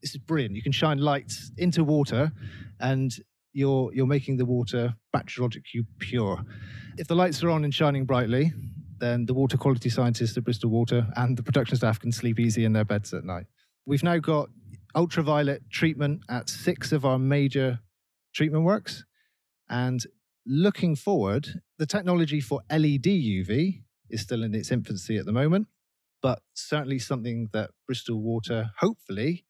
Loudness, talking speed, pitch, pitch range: -27 LUFS, 165 wpm, 130 Hz, 115-150 Hz